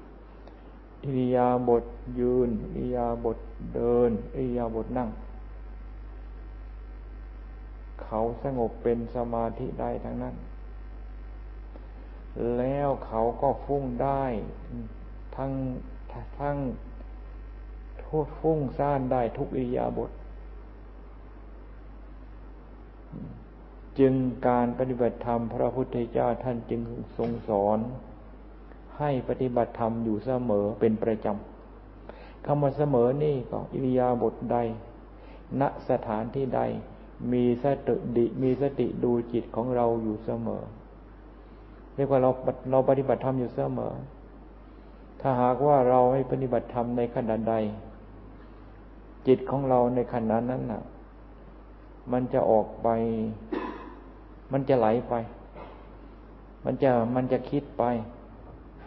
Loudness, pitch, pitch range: -28 LUFS, 120 Hz, 110-130 Hz